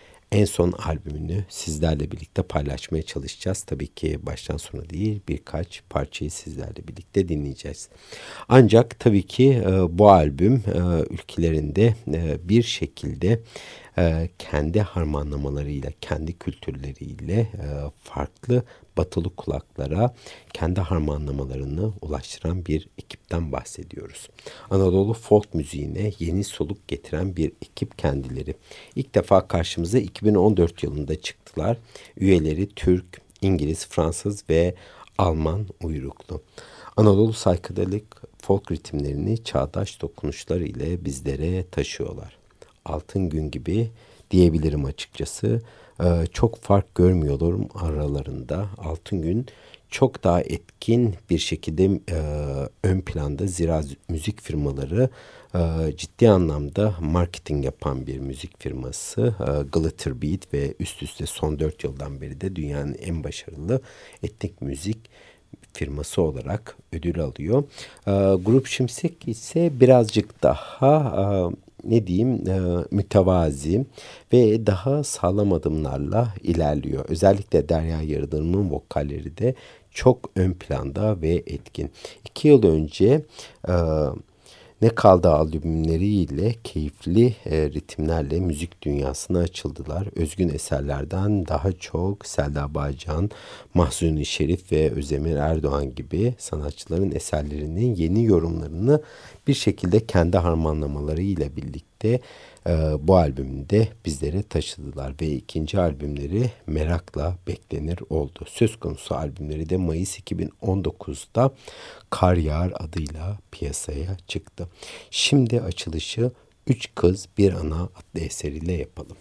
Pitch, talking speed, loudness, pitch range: 85 Hz, 105 wpm, -24 LUFS, 75-105 Hz